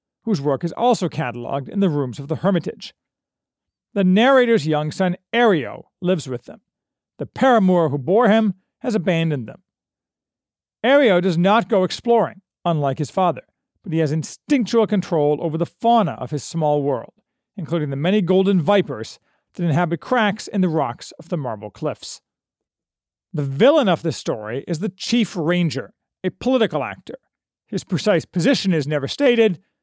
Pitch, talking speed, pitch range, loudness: 180 Hz, 160 wpm, 155-215 Hz, -20 LUFS